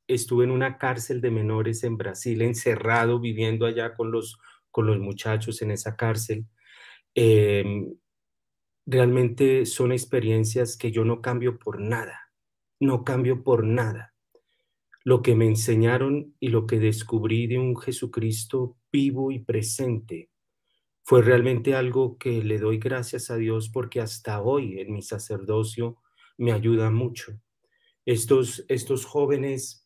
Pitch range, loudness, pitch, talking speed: 110-125 Hz, -25 LUFS, 120 Hz, 135 wpm